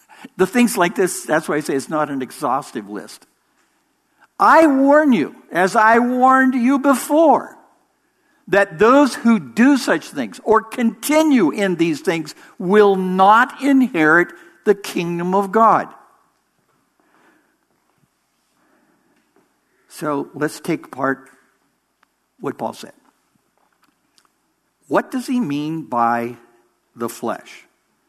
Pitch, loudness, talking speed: 220 Hz, -17 LUFS, 115 wpm